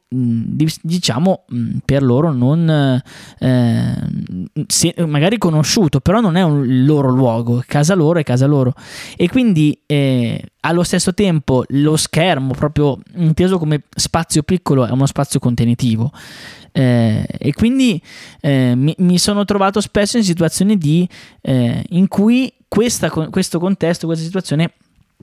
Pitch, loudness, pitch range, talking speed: 155 Hz, -15 LUFS, 130-180 Hz, 130 wpm